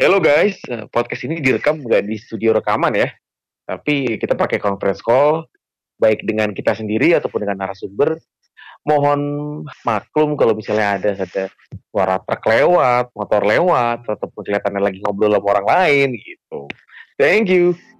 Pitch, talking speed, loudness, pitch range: 110 Hz, 145 wpm, -17 LUFS, 105-145 Hz